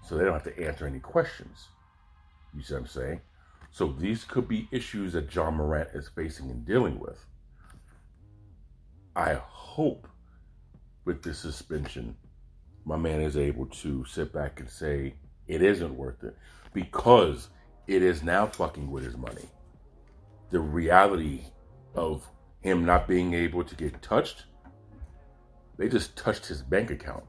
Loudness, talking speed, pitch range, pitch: -29 LUFS, 150 wpm, 70-85 Hz, 75 Hz